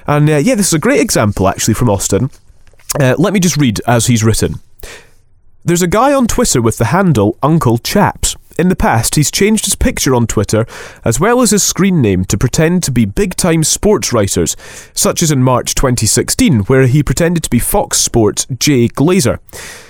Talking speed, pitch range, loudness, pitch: 200 wpm, 115-165 Hz, -12 LUFS, 130 Hz